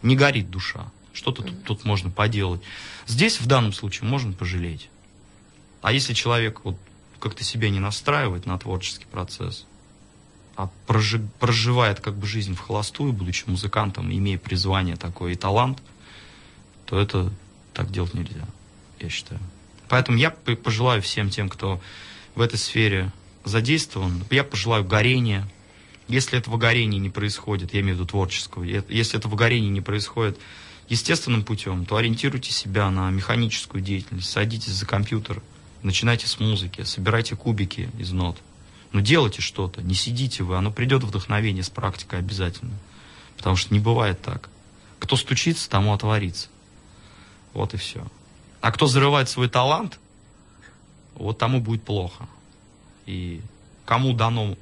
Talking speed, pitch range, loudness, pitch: 140 wpm, 95-115 Hz, -23 LUFS, 105 Hz